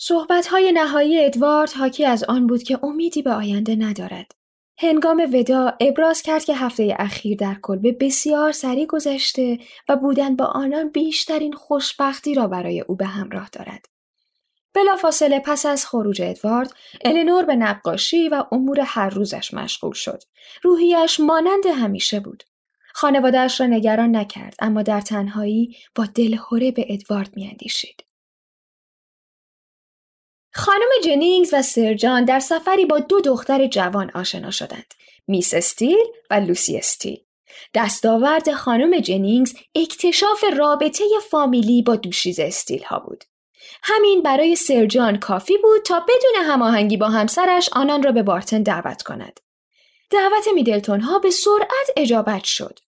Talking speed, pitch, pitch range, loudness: 135 wpm, 275 Hz, 220-320 Hz, -18 LUFS